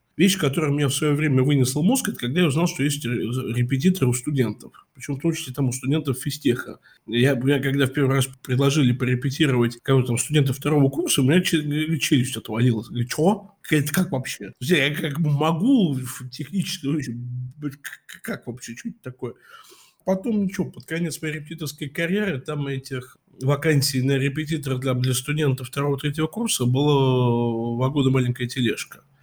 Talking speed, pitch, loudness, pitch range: 155 wpm, 140 Hz, -23 LUFS, 130-155 Hz